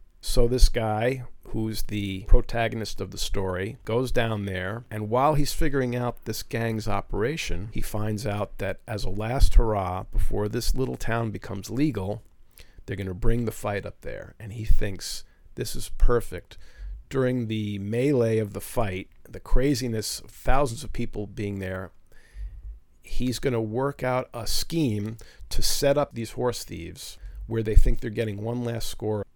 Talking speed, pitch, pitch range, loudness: 170 wpm, 110 Hz, 100-120 Hz, -28 LUFS